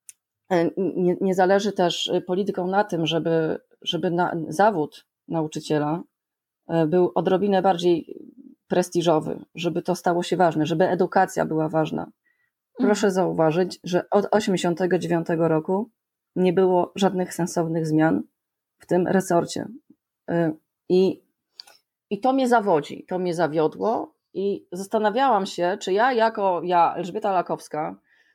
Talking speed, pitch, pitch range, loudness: 120 wpm, 180 Hz, 170-195 Hz, -23 LUFS